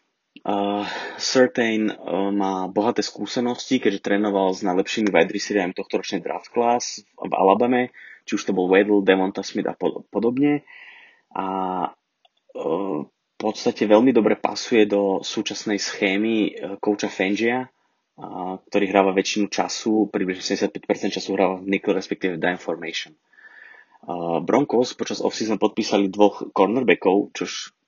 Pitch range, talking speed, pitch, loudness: 95-110 Hz, 140 wpm, 100 Hz, -22 LUFS